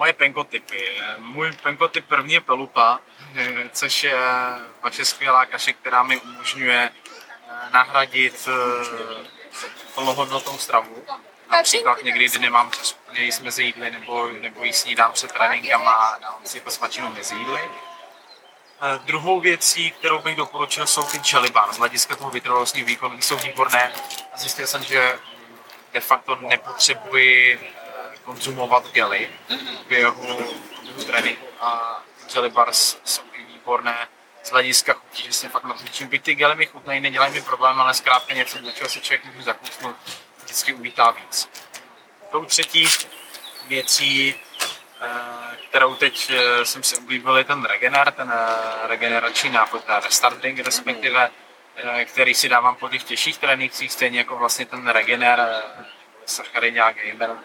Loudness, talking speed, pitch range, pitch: -19 LUFS, 130 wpm, 120-140 Hz, 125 Hz